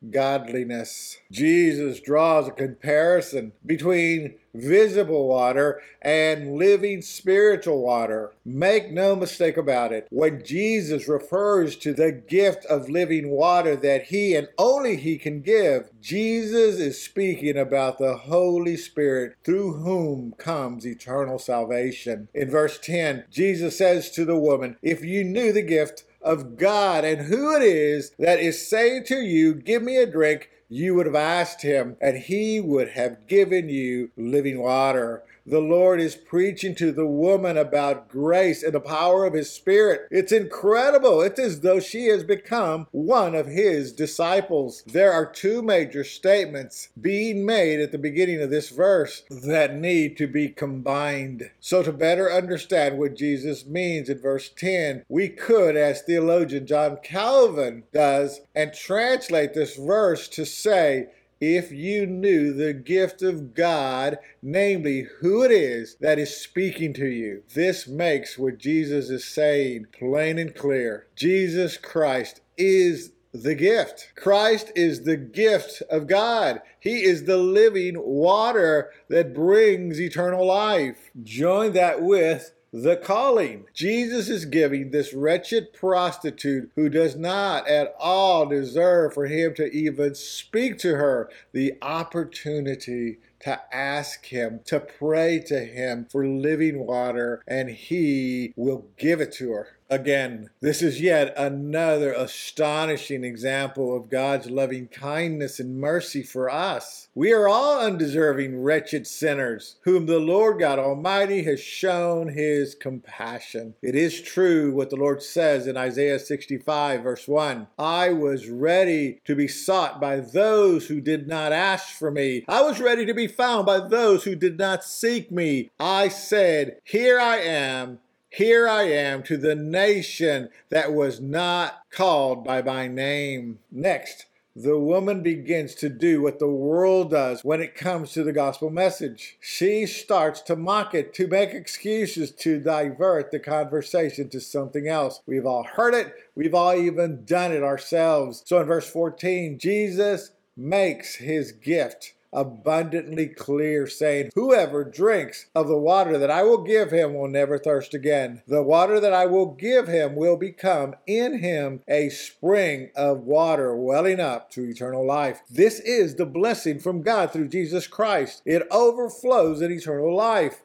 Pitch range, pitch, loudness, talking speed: 140-185 Hz, 155 Hz, -22 LUFS, 150 wpm